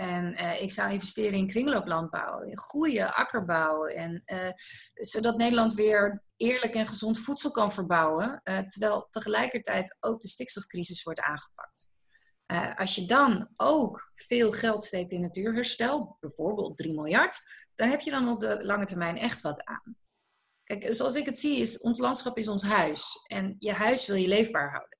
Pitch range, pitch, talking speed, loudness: 190-240 Hz, 215 Hz, 175 wpm, -27 LUFS